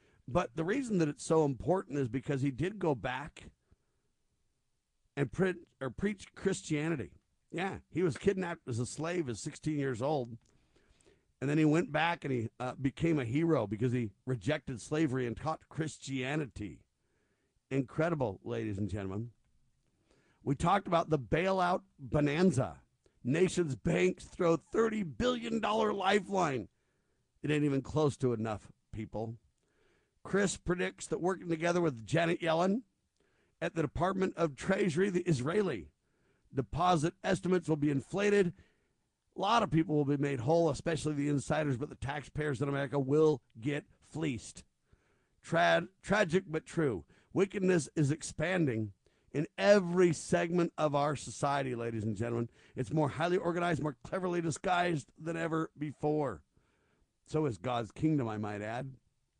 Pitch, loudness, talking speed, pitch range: 155 Hz, -33 LUFS, 145 wpm, 130-175 Hz